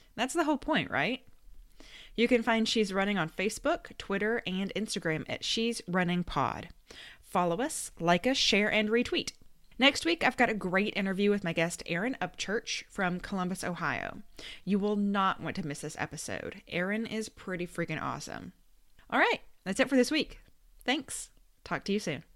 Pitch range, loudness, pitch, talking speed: 180-235 Hz, -31 LUFS, 205 Hz, 175 wpm